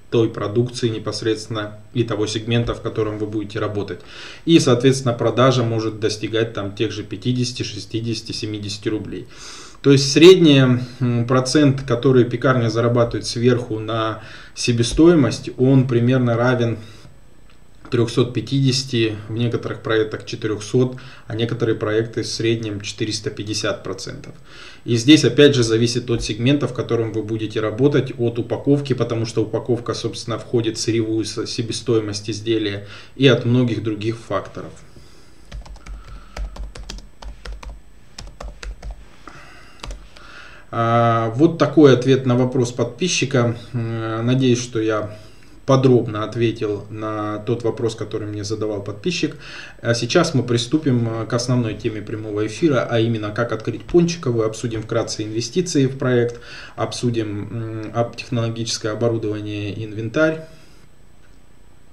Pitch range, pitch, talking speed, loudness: 110-125 Hz, 115 Hz, 115 wpm, -19 LUFS